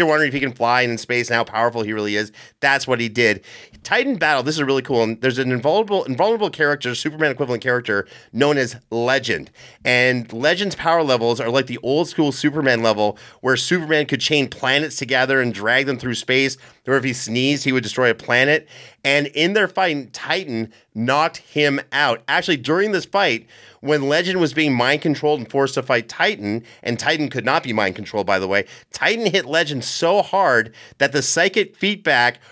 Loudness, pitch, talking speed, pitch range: -19 LUFS, 135 Hz, 200 wpm, 120-150 Hz